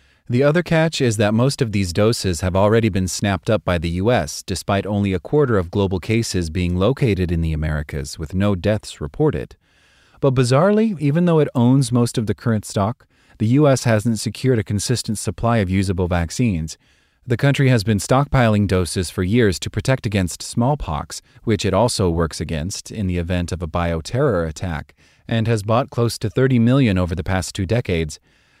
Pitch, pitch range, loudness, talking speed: 105 Hz, 90-125 Hz, -19 LUFS, 190 wpm